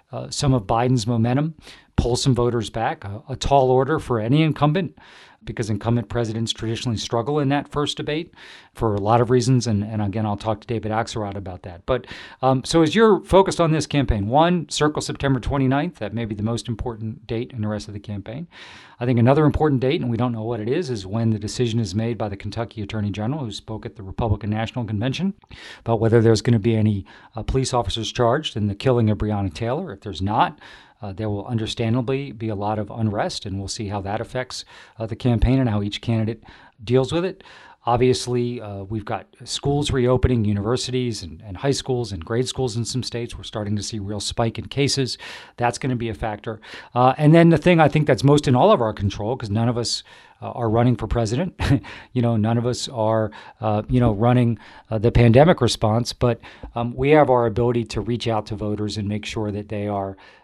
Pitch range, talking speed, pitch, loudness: 105-130 Hz, 225 wpm, 115 Hz, -21 LUFS